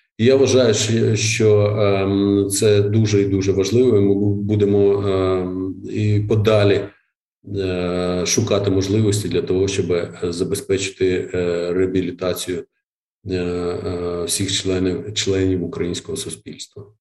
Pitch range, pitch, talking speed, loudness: 95-105 Hz, 100 Hz, 90 wpm, -18 LUFS